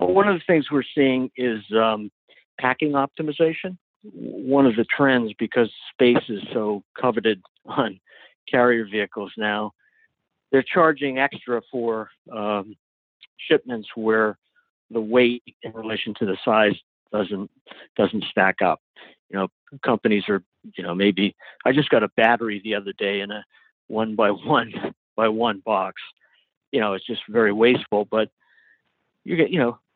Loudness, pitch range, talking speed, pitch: -22 LUFS, 105-140 Hz, 150 wpm, 115 Hz